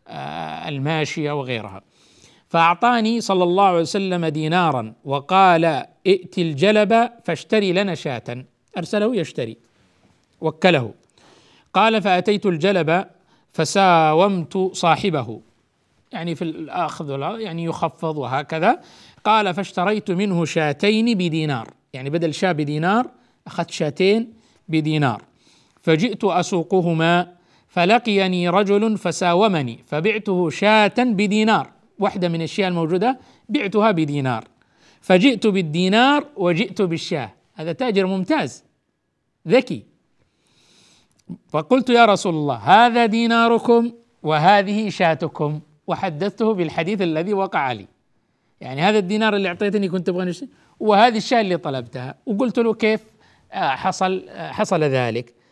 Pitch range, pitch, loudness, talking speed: 160-210 Hz, 185 Hz, -19 LUFS, 100 wpm